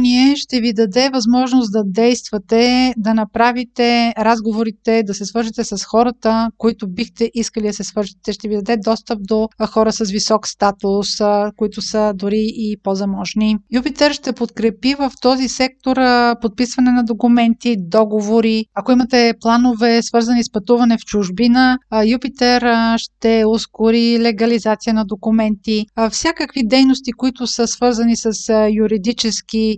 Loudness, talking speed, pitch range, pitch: -16 LUFS, 130 wpm, 215-245 Hz, 230 Hz